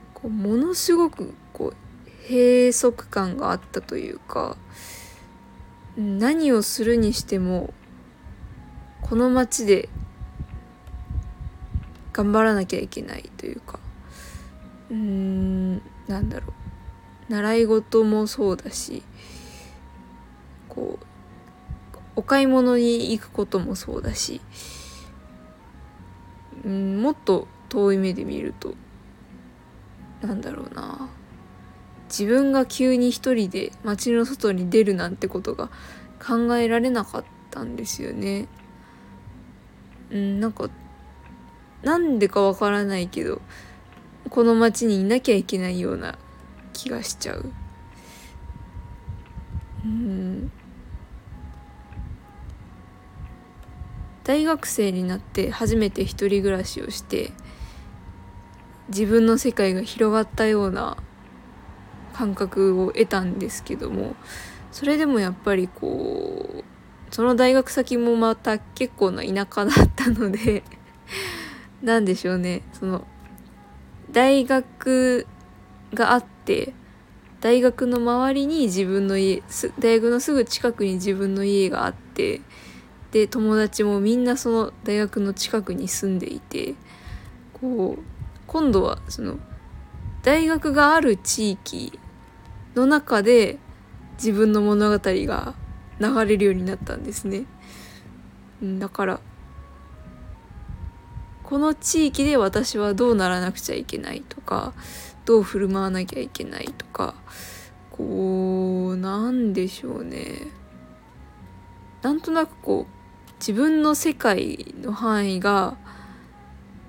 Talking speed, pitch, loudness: 205 characters per minute, 205 Hz, -23 LUFS